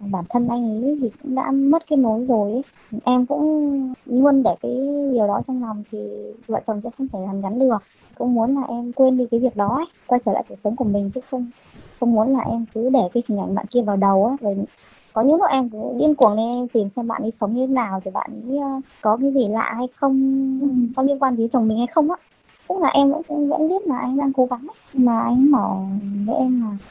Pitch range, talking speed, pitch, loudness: 220-270 Hz, 260 wpm, 245 Hz, -20 LUFS